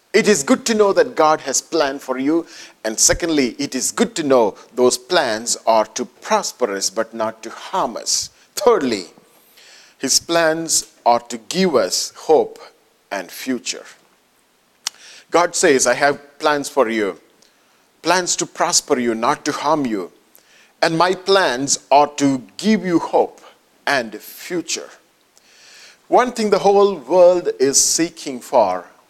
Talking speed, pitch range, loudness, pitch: 150 wpm, 130-180 Hz, -17 LUFS, 150 Hz